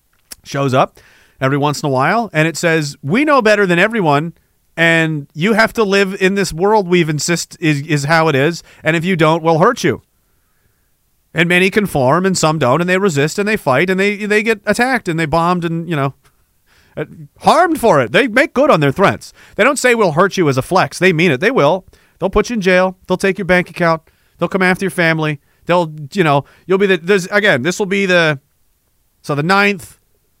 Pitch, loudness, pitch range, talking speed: 175 Hz, -14 LUFS, 155-200 Hz, 225 wpm